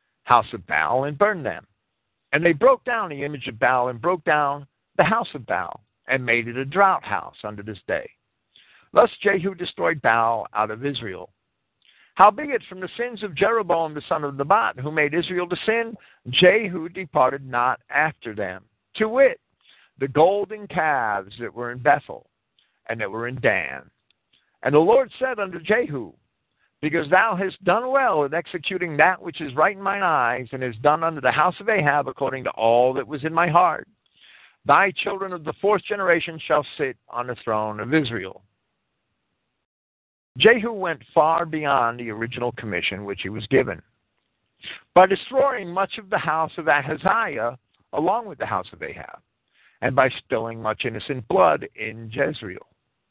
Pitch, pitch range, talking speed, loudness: 150 Hz, 120-185 Hz, 175 wpm, -22 LUFS